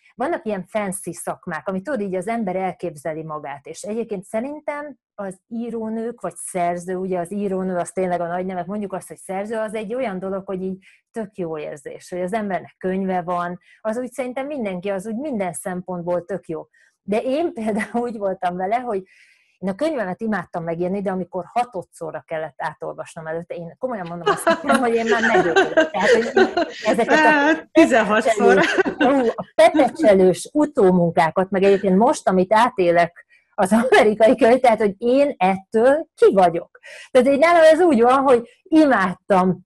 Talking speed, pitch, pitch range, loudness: 160 wpm, 200 Hz, 180-250 Hz, -19 LUFS